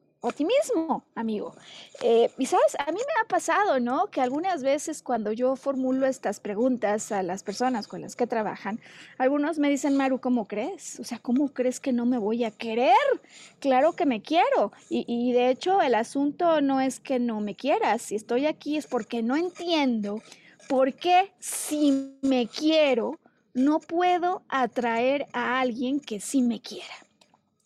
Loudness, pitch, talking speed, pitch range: -26 LUFS, 260 Hz, 170 wpm, 235-300 Hz